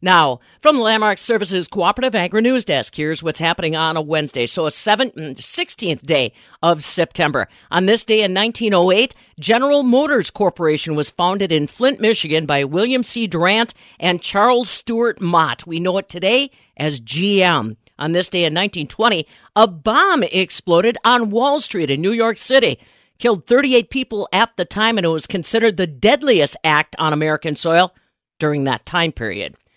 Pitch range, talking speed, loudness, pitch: 160-230 Hz, 170 wpm, -17 LUFS, 185 Hz